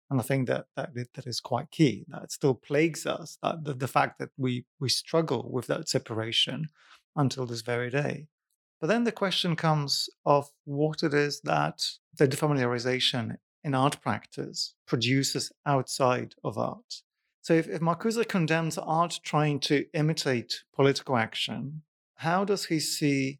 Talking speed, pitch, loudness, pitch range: 160 wpm, 145 Hz, -28 LUFS, 130-160 Hz